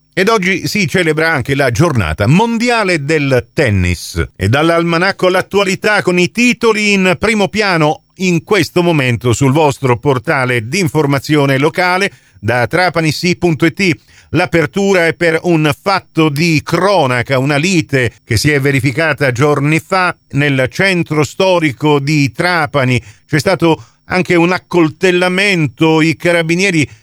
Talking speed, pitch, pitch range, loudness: 125 wpm, 160 Hz, 140-180 Hz, -12 LUFS